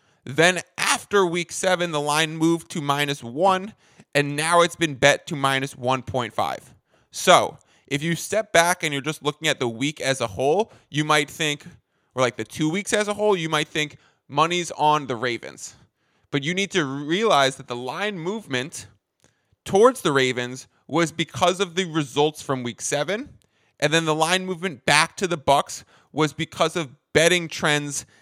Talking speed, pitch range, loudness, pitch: 180 wpm, 135-170 Hz, -22 LUFS, 150 Hz